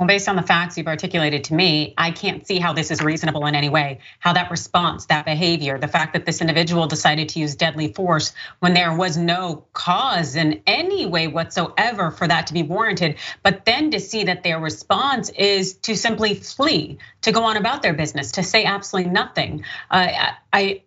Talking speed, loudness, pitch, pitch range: 205 wpm, -19 LUFS, 175 Hz, 160-195 Hz